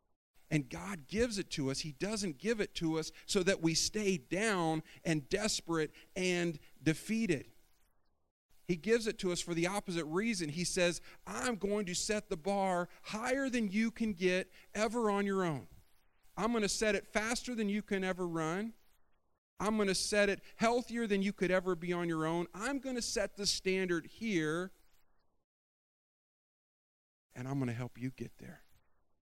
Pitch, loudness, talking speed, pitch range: 185 Hz, -35 LUFS, 180 wpm, 165-210 Hz